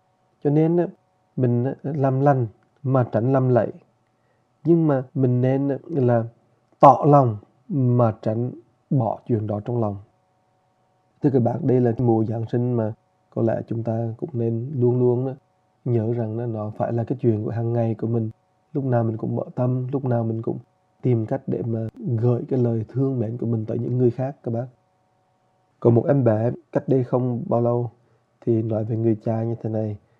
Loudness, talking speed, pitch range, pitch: -22 LUFS, 190 wpm, 110-130 Hz, 120 Hz